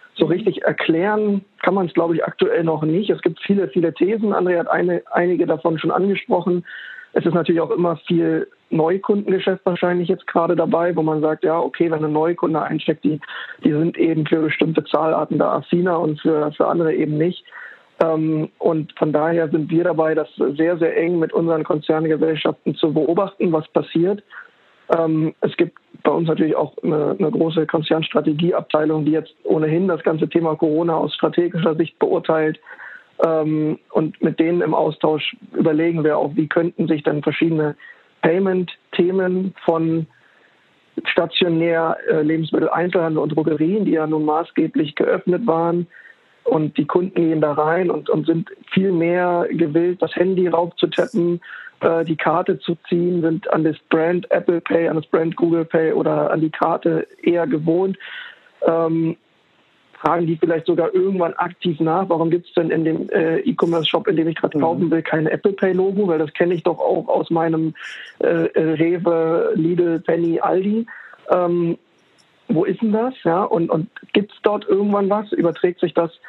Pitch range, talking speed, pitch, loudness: 160-180 Hz, 170 wpm, 165 Hz, -19 LUFS